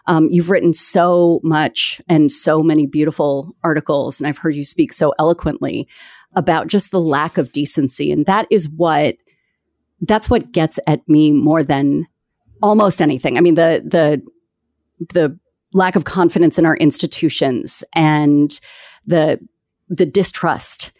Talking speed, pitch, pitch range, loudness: 145 wpm, 160 Hz, 150-175 Hz, -15 LUFS